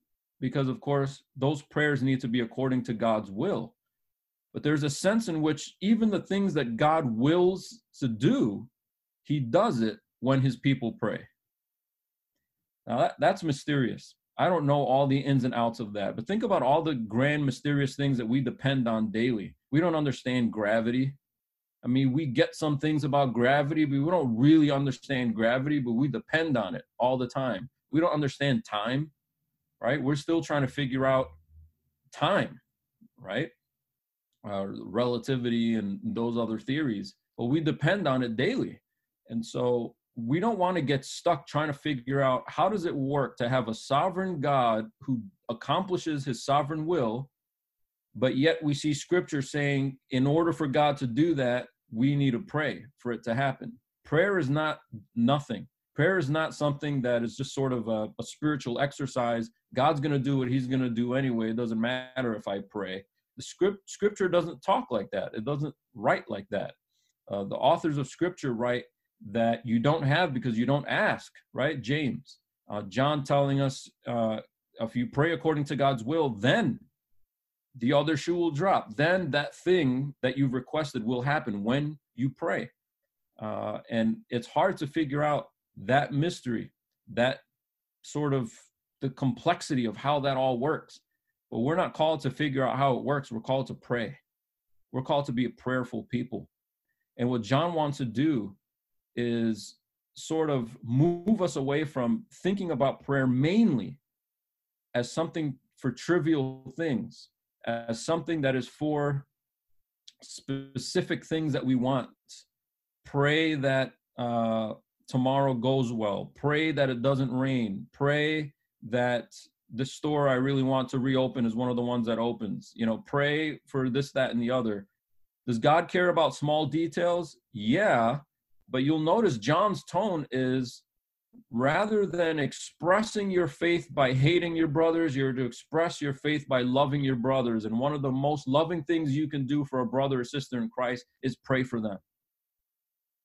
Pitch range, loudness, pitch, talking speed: 120-150 Hz, -28 LUFS, 135 Hz, 170 wpm